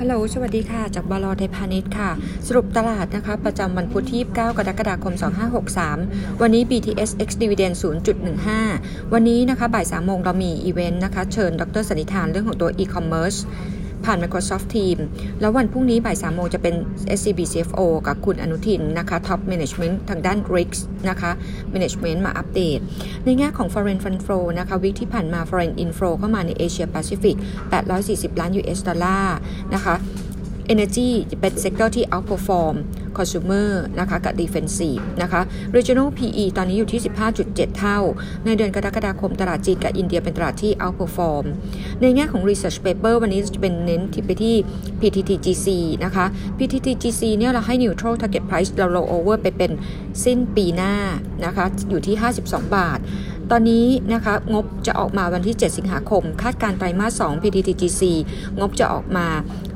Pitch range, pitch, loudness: 180-220 Hz, 195 Hz, -21 LUFS